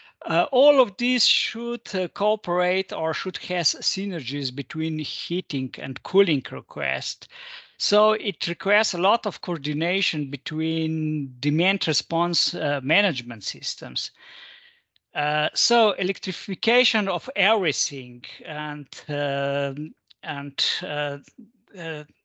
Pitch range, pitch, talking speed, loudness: 145-200 Hz, 170 Hz, 105 wpm, -23 LUFS